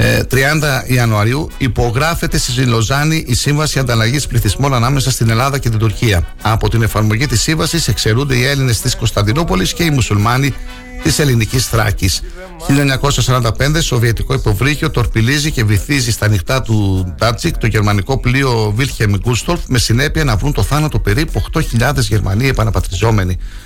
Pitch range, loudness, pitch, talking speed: 110-140 Hz, -14 LUFS, 120 Hz, 140 wpm